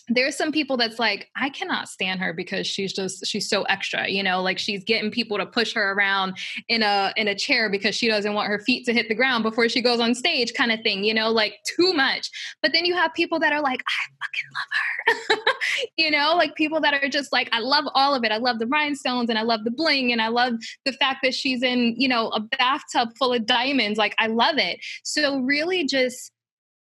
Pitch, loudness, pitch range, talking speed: 240 Hz, -22 LUFS, 215-285 Hz, 245 wpm